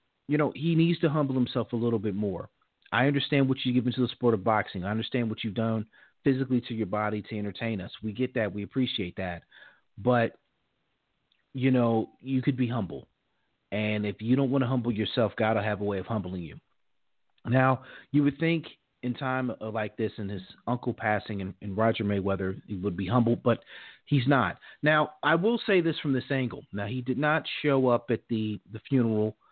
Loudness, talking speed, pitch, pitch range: -28 LUFS, 205 wpm, 115 Hz, 105-130 Hz